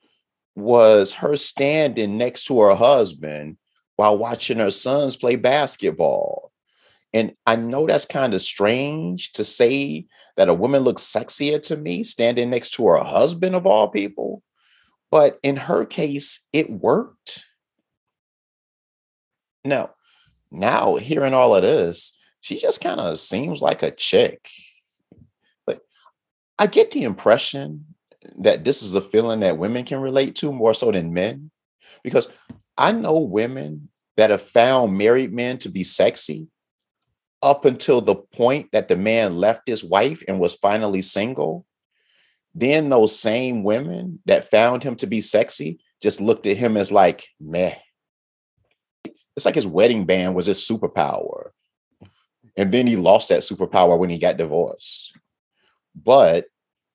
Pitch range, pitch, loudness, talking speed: 105-160 Hz, 125 Hz, -19 LUFS, 145 wpm